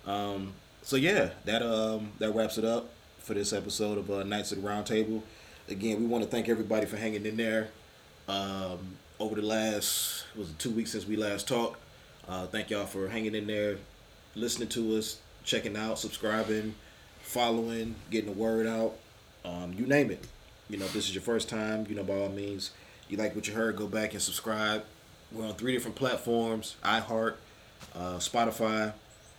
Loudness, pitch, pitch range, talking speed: -32 LUFS, 110 Hz, 100-110 Hz, 190 wpm